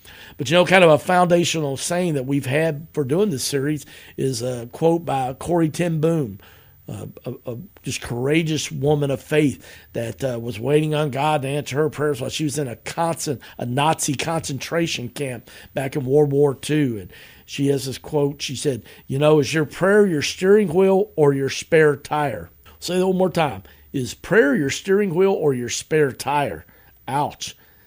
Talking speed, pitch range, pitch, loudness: 195 wpm, 135-160 Hz, 150 Hz, -20 LUFS